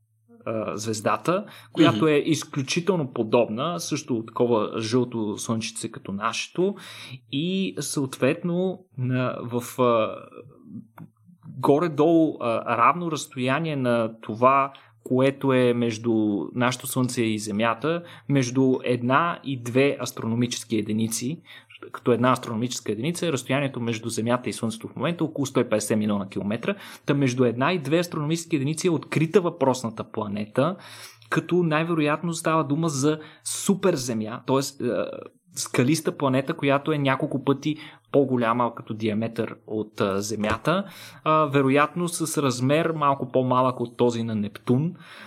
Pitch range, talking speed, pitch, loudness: 115-155 Hz, 115 wpm, 130 Hz, -24 LUFS